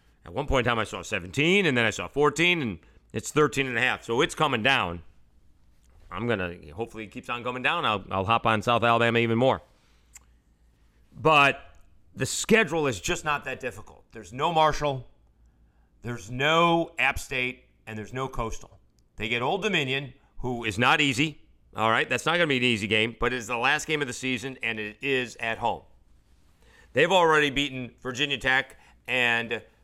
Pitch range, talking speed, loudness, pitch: 95-135 Hz, 190 wpm, -25 LUFS, 120 Hz